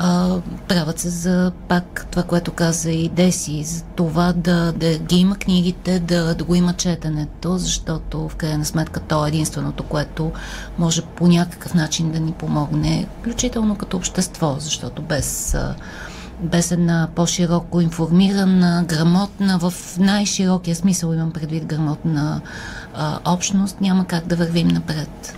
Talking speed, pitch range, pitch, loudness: 140 wpm, 160-180 Hz, 170 Hz, -20 LUFS